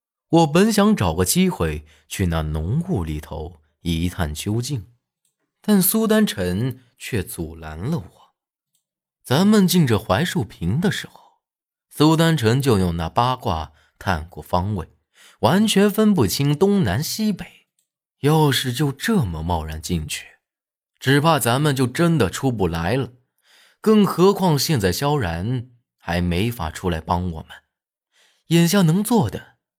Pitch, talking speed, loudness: 130 Hz, 195 characters per minute, -20 LUFS